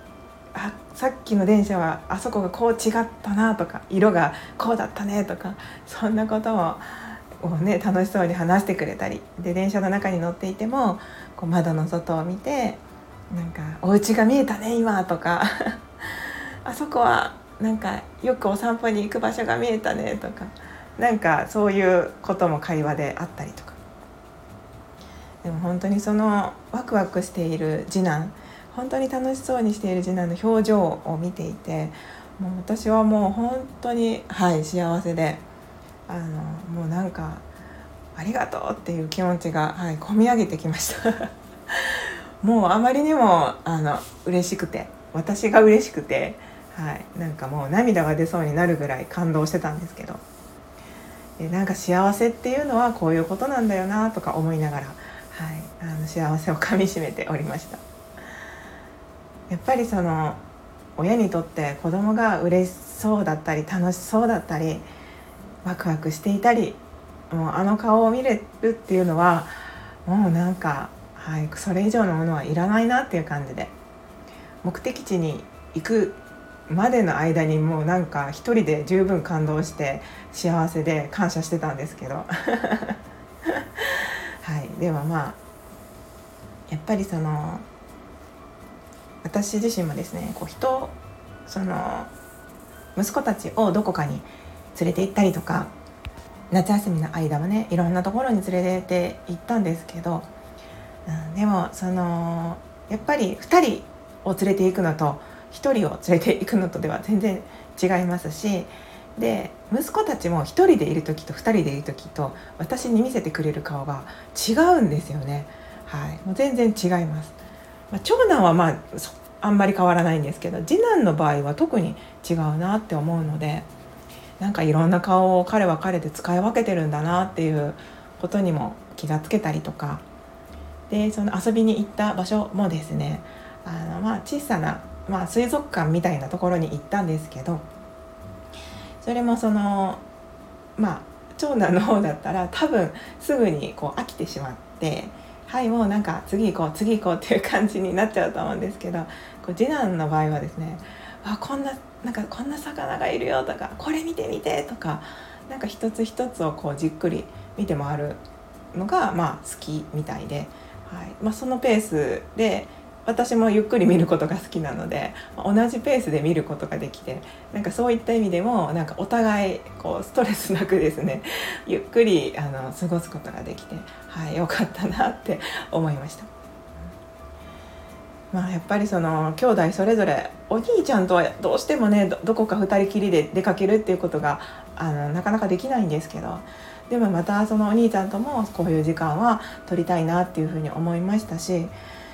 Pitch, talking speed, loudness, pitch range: 180 Hz, 315 characters per minute, -23 LUFS, 160-215 Hz